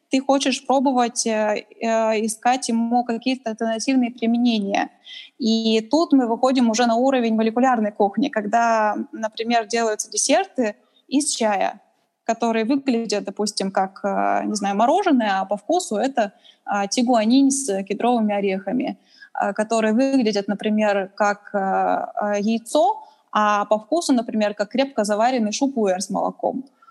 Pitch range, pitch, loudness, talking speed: 210-265 Hz, 230 Hz, -21 LUFS, 120 wpm